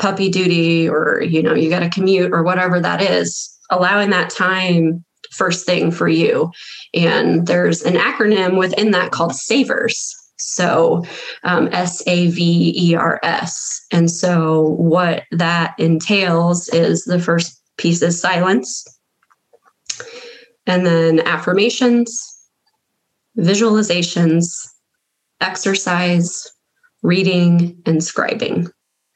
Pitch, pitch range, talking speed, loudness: 180 Hz, 170-190 Hz, 110 wpm, -16 LUFS